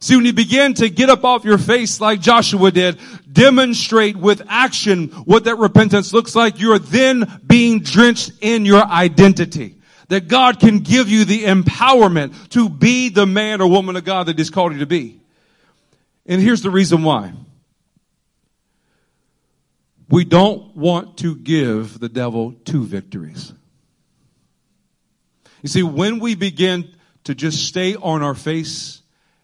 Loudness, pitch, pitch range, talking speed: -14 LUFS, 195 Hz, 165-225 Hz, 150 wpm